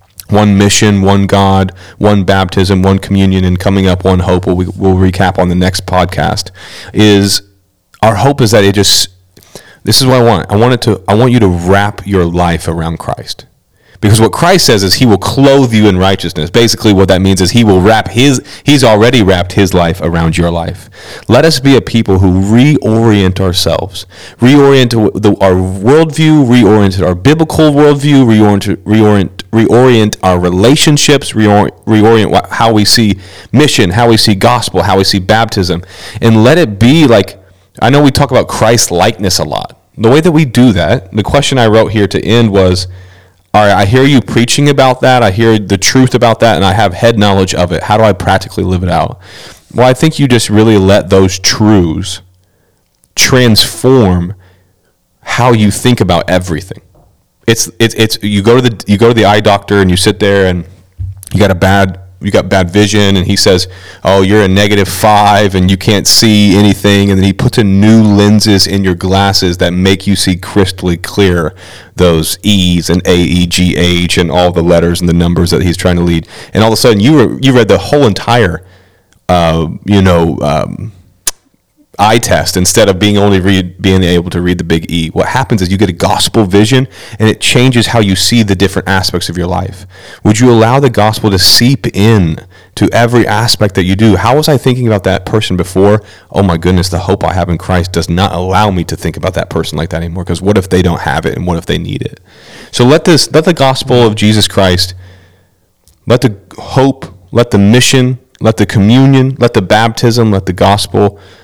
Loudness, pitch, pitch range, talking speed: -8 LUFS, 100 Hz, 90-115 Hz, 205 wpm